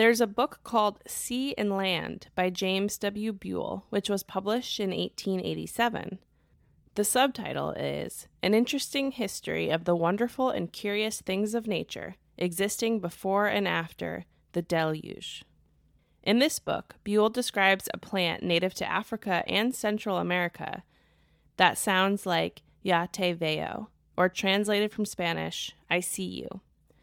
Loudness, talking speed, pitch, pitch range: -29 LUFS, 135 wpm, 200 Hz, 180-220 Hz